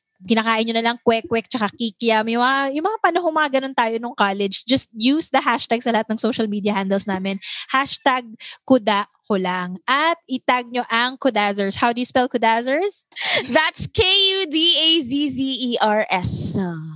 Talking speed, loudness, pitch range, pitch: 150 wpm, -19 LUFS, 215-270 Hz, 240 Hz